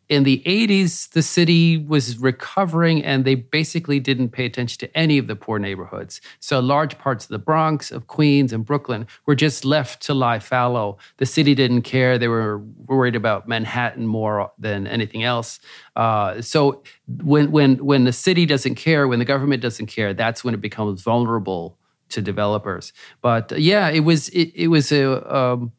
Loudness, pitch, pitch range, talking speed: -19 LUFS, 130 Hz, 115-150 Hz, 185 wpm